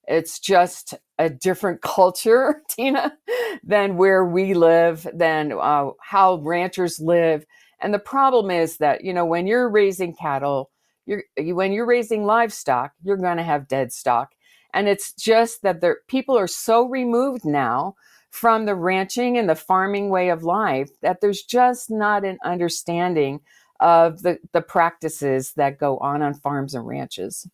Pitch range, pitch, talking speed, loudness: 160-215 Hz, 185 Hz, 160 wpm, -20 LUFS